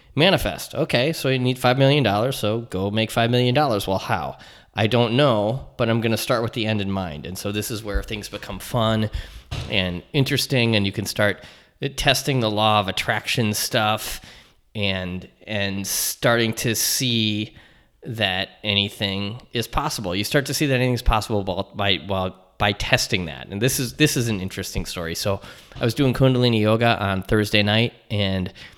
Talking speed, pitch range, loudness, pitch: 180 wpm, 100-120 Hz, -21 LUFS, 110 Hz